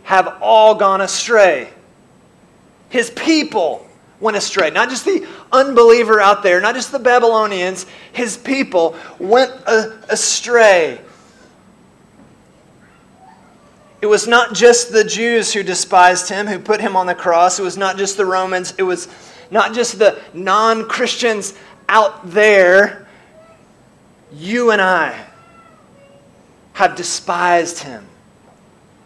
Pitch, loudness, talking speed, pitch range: 210 Hz, -14 LUFS, 120 wpm, 190-235 Hz